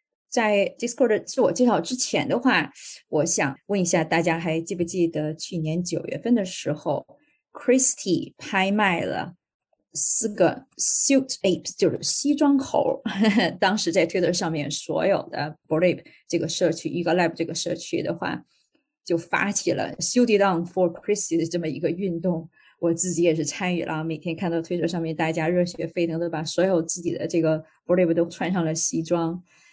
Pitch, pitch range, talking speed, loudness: 175 Hz, 165-200 Hz, 365 characters per minute, -23 LUFS